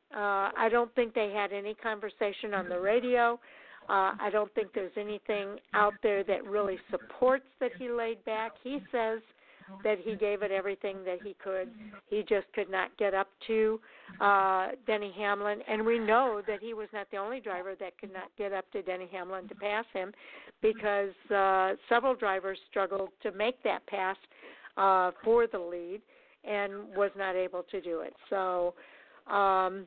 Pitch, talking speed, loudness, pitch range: 205 Hz, 180 wpm, -31 LUFS, 195-220 Hz